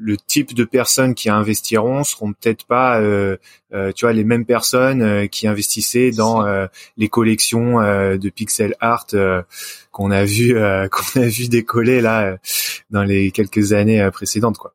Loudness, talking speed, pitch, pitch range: -16 LUFS, 185 wpm, 110 Hz, 100-120 Hz